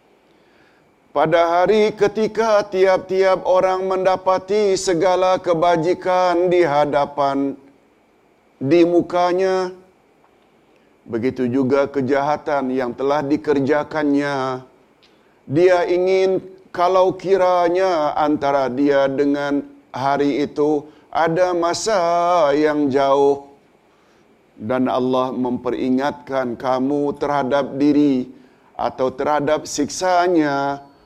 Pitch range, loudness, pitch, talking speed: 140-180 Hz, -18 LUFS, 150 Hz, 75 wpm